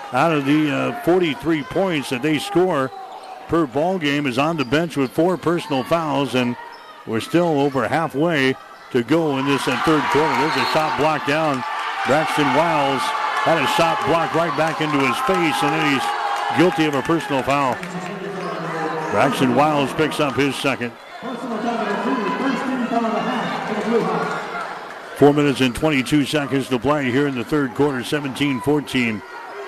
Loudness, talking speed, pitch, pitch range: -20 LUFS, 150 wpm, 150 Hz, 135-175 Hz